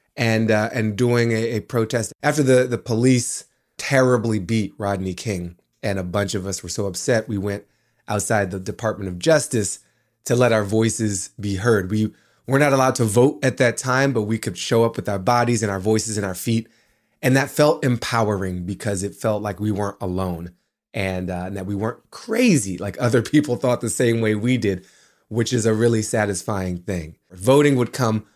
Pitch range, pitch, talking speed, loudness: 100-120 Hz, 110 Hz, 200 wpm, -21 LUFS